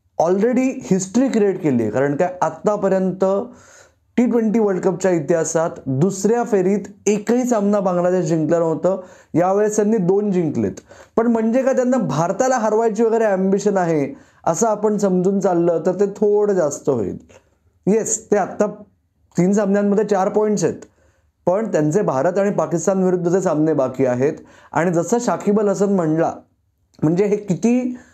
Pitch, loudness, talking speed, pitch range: 195 Hz, -18 LUFS, 145 wpm, 170-215 Hz